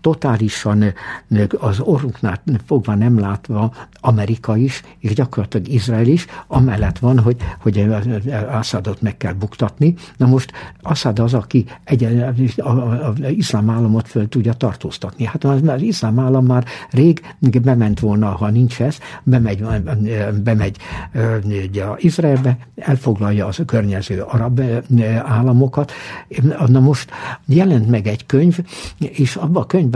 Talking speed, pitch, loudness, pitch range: 135 wpm, 120 Hz, -17 LUFS, 110-135 Hz